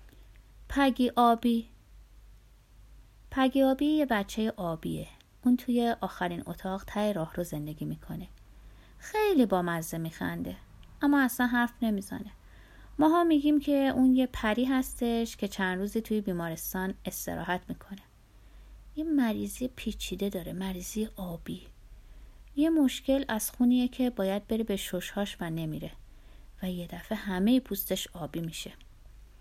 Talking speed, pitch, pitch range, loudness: 125 wpm, 200 Hz, 170-250 Hz, -30 LUFS